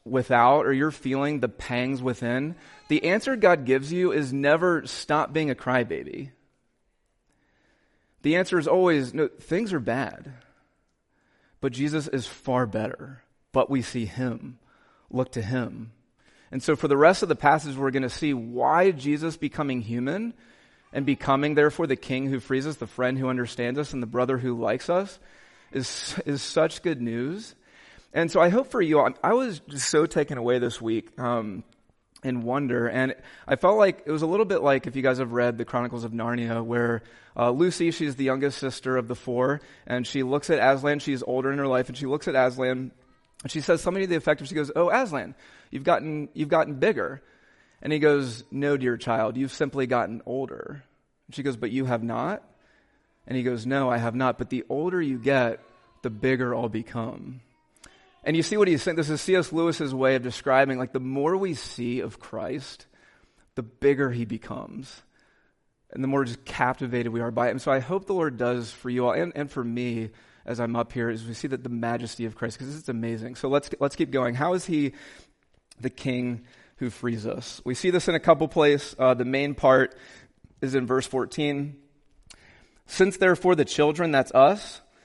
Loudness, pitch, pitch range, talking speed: -25 LUFS, 135 Hz, 125-150 Hz, 200 wpm